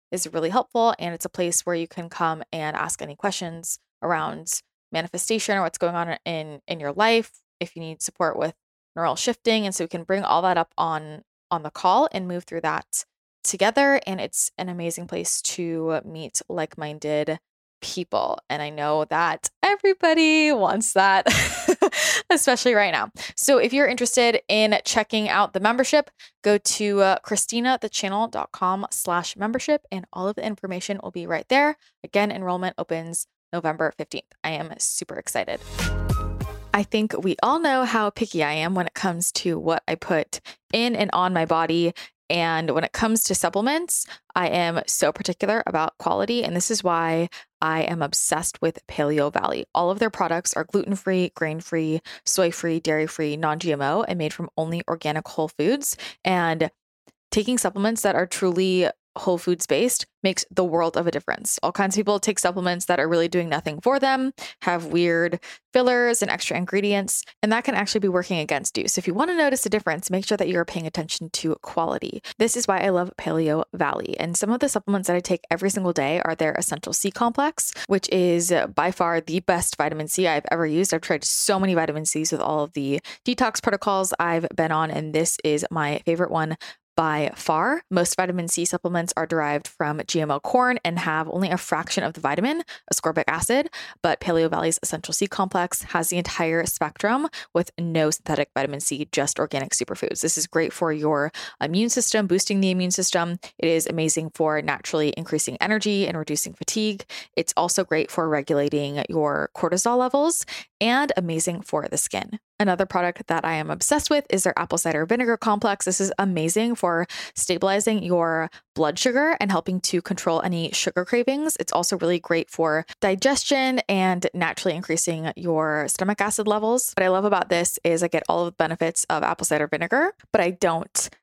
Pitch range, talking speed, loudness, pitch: 165-210 Hz, 190 wpm, -23 LUFS, 180 Hz